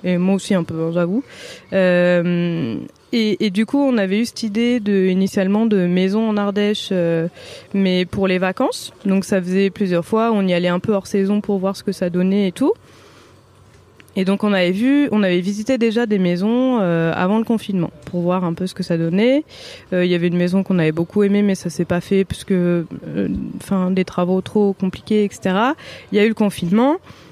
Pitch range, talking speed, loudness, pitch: 175-210 Hz, 220 wpm, -18 LUFS, 190 Hz